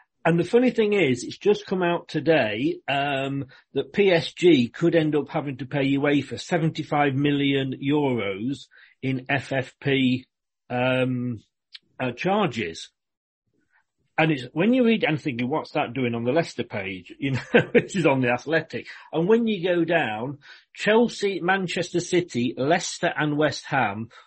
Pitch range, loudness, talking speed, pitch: 130-175 Hz, -24 LUFS, 150 wpm, 145 Hz